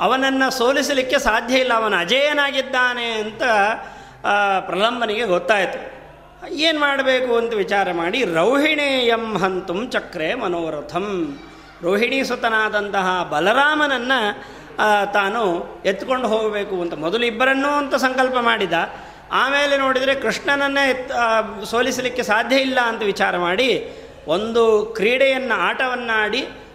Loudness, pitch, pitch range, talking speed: -19 LUFS, 235 Hz, 205-265 Hz, 100 wpm